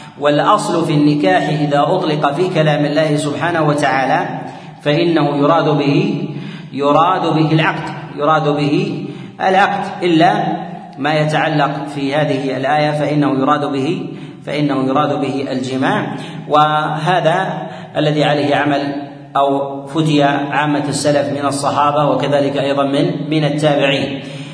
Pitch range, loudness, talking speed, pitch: 140-155 Hz, -15 LUFS, 115 wpm, 150 Hz